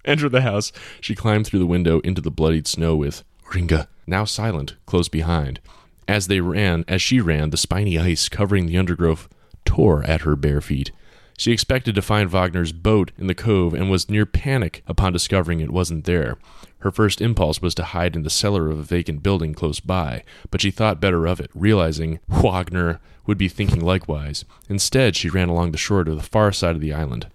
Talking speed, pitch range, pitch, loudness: 205 wpm, 80-100 Hz, 90 Hz, -20 LUFS